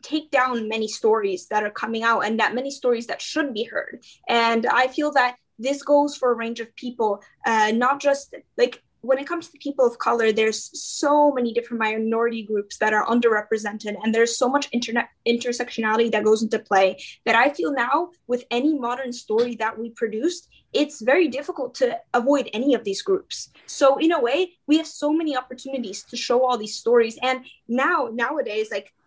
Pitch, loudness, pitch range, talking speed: 245 Hz, -22 LUFS, 225-285 Hz, 195 wpm